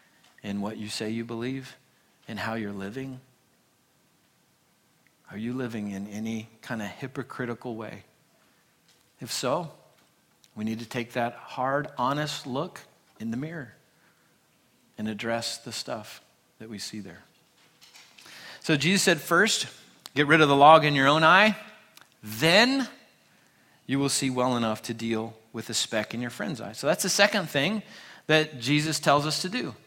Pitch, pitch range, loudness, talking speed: 130 Hz, 115-155 Hz, -26 LUFS, 160 wpm